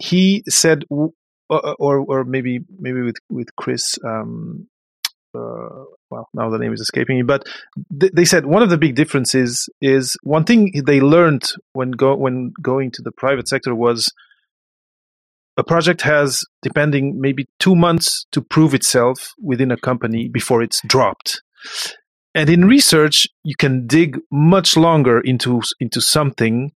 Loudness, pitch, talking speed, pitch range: -16 LUFS, 140 Hz, 150 wpm, 125-165 Hz